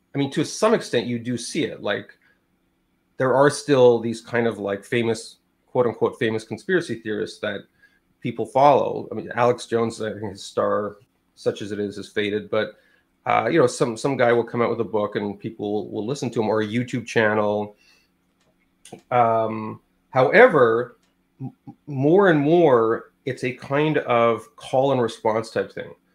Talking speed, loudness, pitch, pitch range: 180 wpm, -22 LUFS, 115 Hz, 105-125 Hz